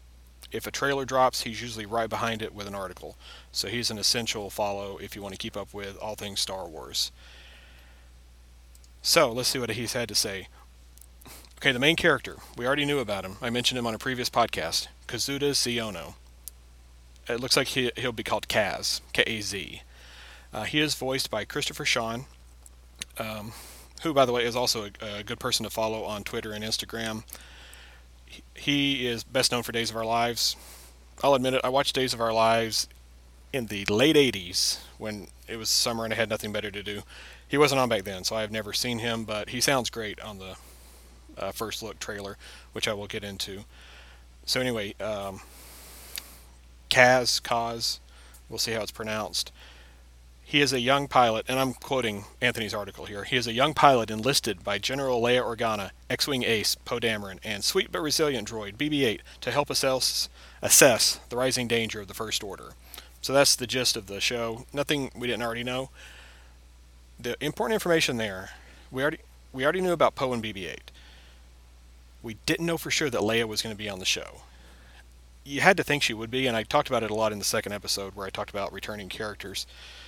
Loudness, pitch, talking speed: -26 LUFS, 110 Hz, 195 wpm